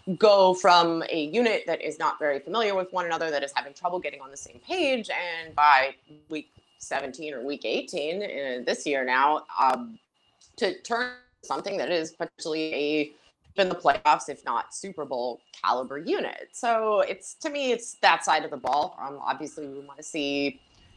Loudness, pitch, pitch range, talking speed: -26 LUFS, 170 Hz, 150-225 Hz, 185 wpm